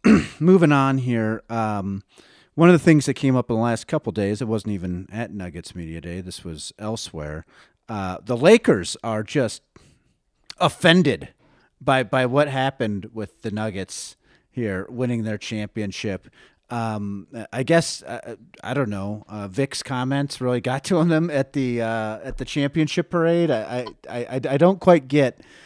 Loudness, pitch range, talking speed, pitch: -22 LUFS, 105-140 Hz, 165 wpm, 120 Hz